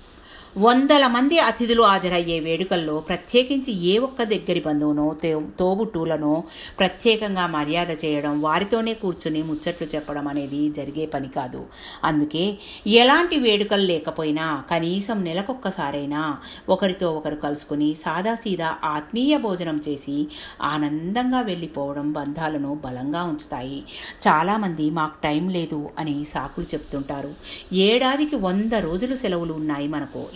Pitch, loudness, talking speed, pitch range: 165 Hz, -22 LUFS, 105 wpm, 150-205 Hz